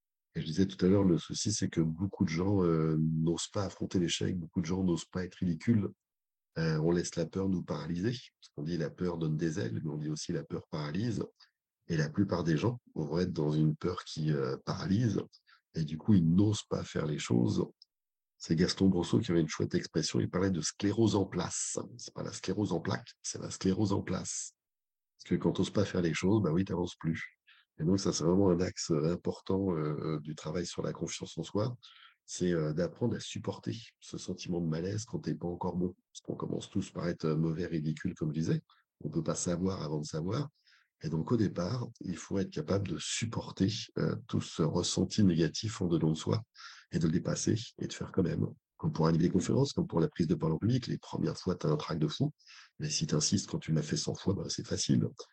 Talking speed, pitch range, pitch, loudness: 240 wpm, 80-100 Hz, 90 Hz, -33 LUFS